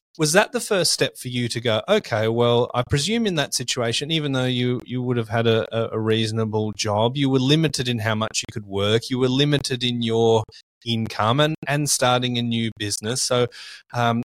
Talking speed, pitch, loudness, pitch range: 210 wpm, 120 Hz, -21 LUFS, 115-135 Hz